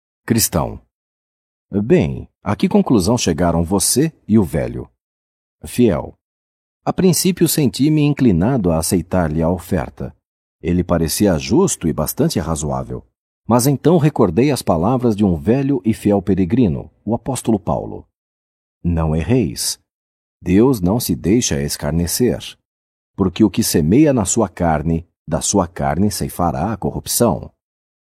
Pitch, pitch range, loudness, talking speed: 95 Hz, 80-120 Hz, -17 LUFS, 125 wpm